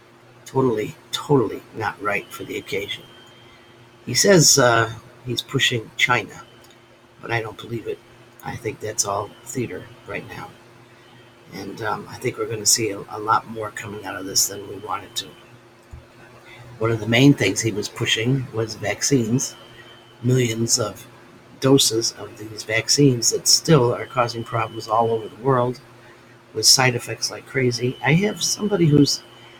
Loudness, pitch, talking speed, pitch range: -20 LUFS, 120 Hz, 160 wpm, 115-125 Hz